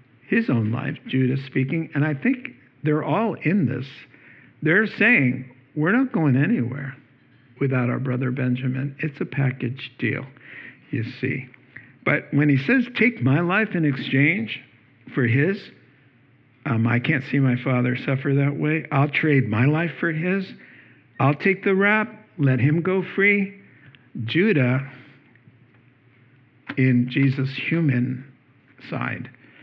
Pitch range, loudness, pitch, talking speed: 125-155 Hz, -22 LUFS, 135 Hz, 135 wpm